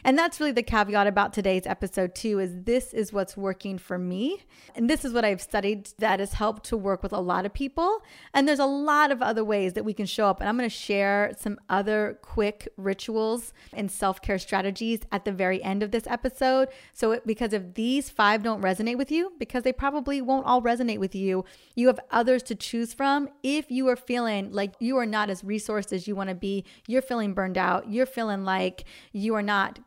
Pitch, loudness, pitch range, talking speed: 215 Hz, -27 LUFS, 200-250 Hz, 220 wpm